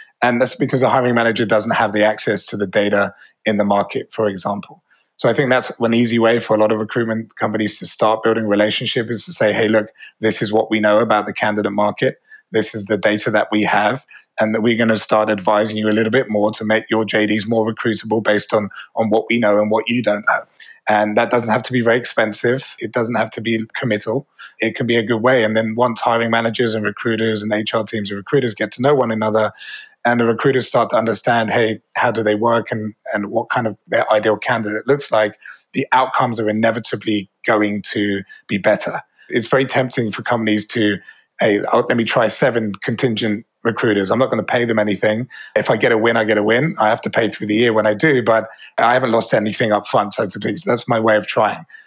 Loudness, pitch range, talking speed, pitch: -17 LUFS, 105-120 Hz, 240 wpm, 110 Hz